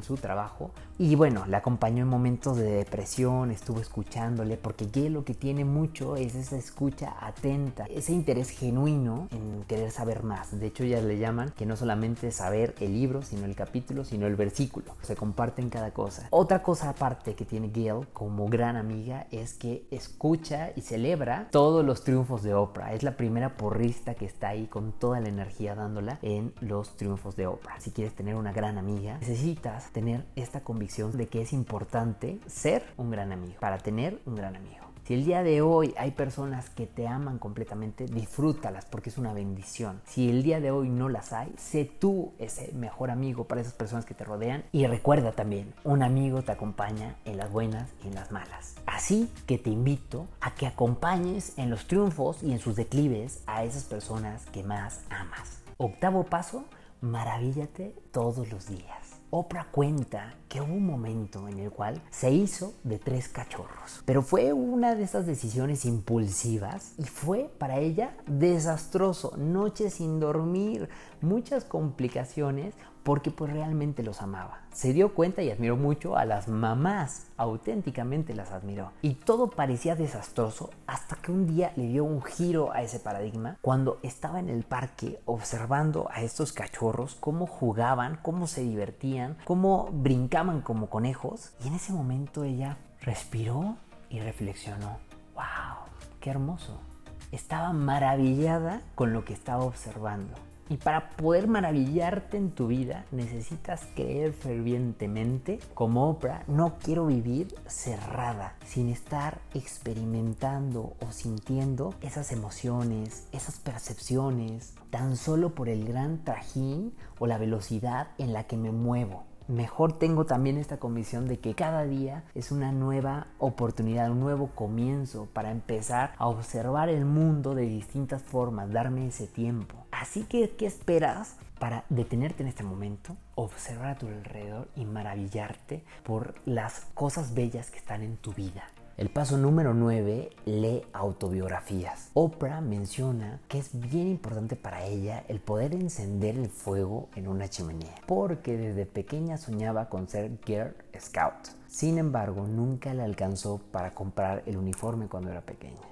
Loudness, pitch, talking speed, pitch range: -31 LUFS, 120 Hz, 160 wpm, 110-145 Hz